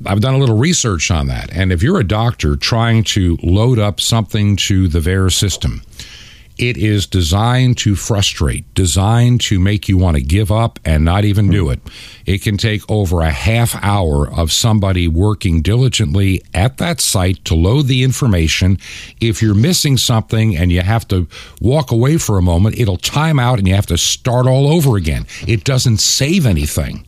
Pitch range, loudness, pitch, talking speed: 90-115 Hz, -14 LUFS, 105 Hz, 190 wpm